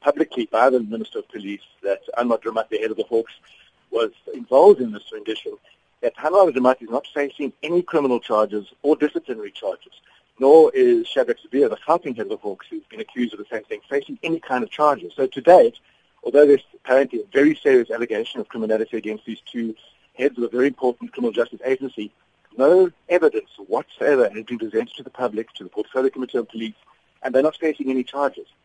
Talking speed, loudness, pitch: 205 wpm, -20 LUFS, 145 Hz